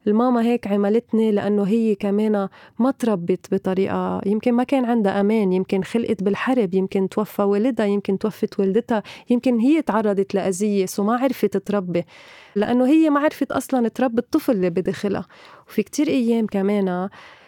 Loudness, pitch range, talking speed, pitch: -21 LUFS, 195-240 Hz, 150 wpm, 210 Hz